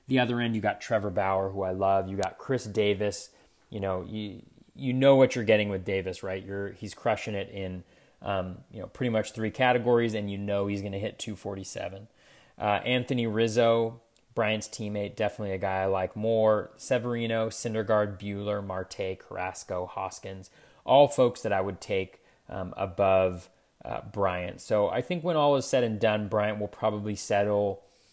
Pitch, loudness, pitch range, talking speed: 105 Hz, -28 LUFS, 95-115 Hz, 180 wpm